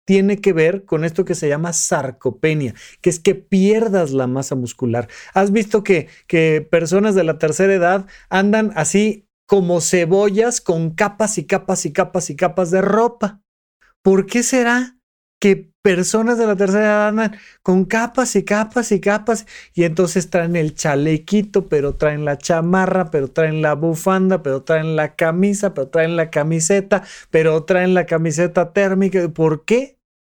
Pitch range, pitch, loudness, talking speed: 160-205 Hz, 185 Hz, -17 LUFS, 165 wpm